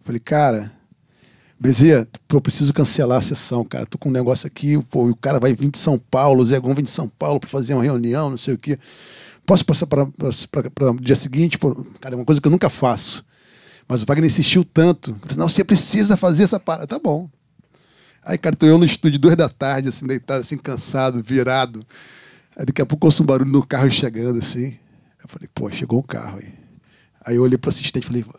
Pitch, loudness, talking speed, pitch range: 140 Hz, -17 LUFS, 225 wpm, 130-155 Hz